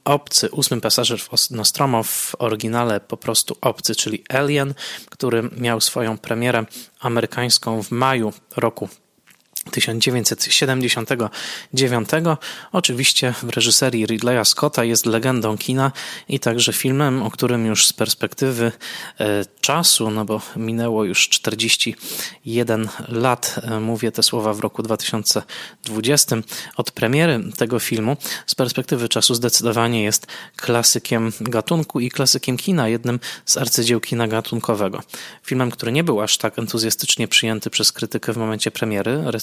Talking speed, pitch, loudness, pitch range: 125 wpm, 115 Hz, -18 LUFS, 110-130 Hz